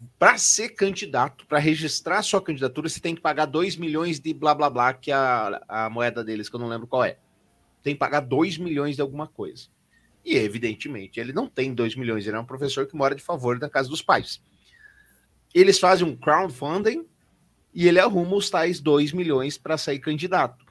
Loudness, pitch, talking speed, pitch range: -23 LUFS, 150 Hz, 205 wpm, 130-175 Hz